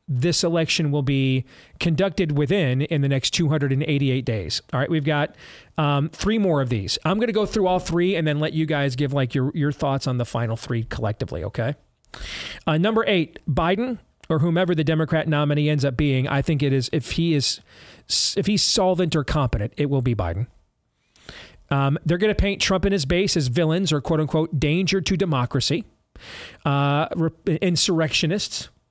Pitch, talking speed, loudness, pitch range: 155 Hz, 185 wpm, -22 LUFS, 135-175 Hz